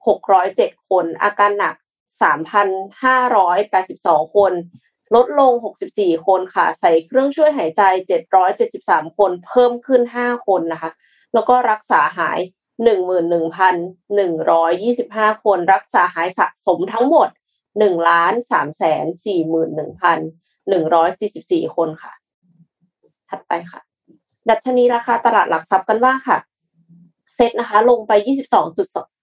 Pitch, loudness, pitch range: 195 Hz, -16 LUFS, 170-240 Hz